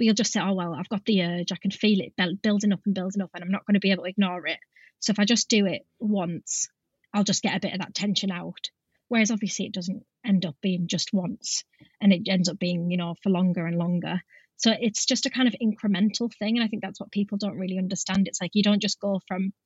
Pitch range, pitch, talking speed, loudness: 185-210 Hz, 195 Hz, 270 wpm, -26 LUFS